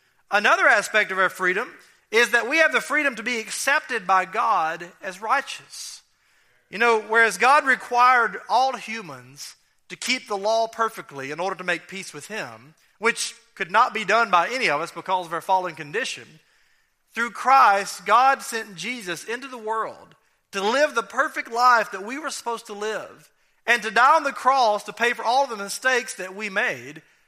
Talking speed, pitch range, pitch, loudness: 185 wpm, 190-245 Hz, 225 Hz, -21 LUFS